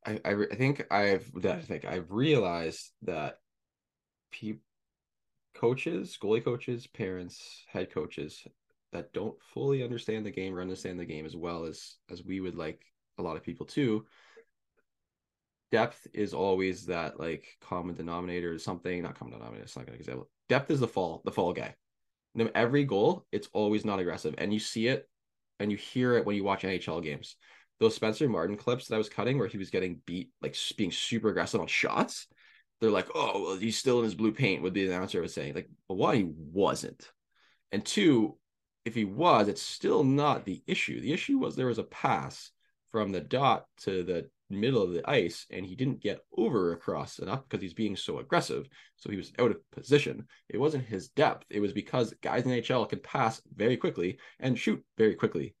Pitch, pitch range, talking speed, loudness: 105 Hz, 90-120 Hz, 195 wpm, -31 LUFS